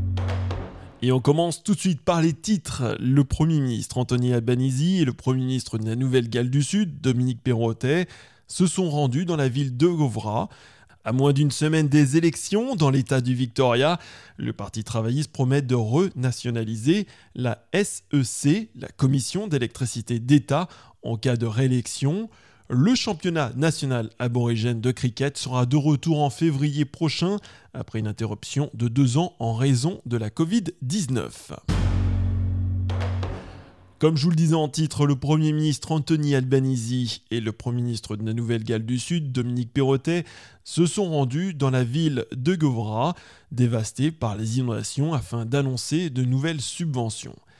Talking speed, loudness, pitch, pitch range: 155 wpm, -24 LUFS, 130 Hz, 115-155 Hz